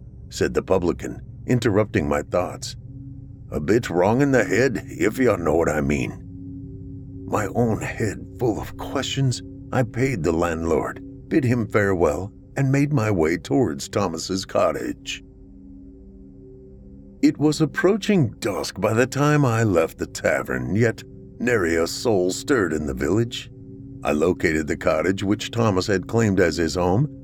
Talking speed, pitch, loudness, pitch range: 150 wpm, 110 Hz, -22 LUFS, 90-130 Hz